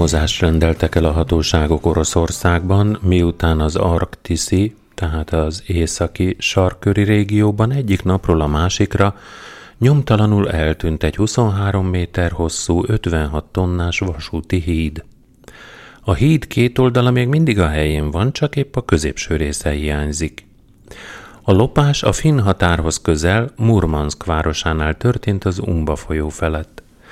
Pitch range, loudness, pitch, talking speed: 80-105 Hz, -17 LUFS, 90 Hz, 120 wpm